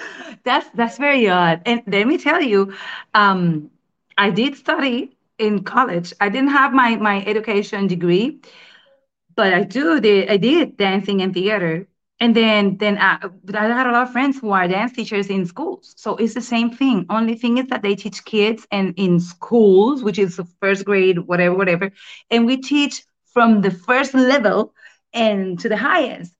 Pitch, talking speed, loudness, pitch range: 215 Hz, 185 wpm, -17 LUFS, 195-250 Hz